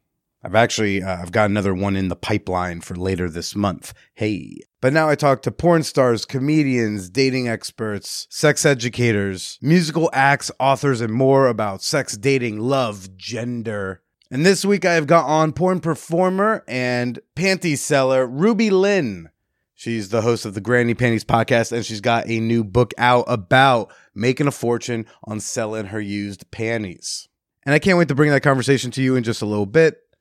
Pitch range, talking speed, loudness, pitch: 110-145 Hz, 180 wpm, -19 LUFS, 120 Hz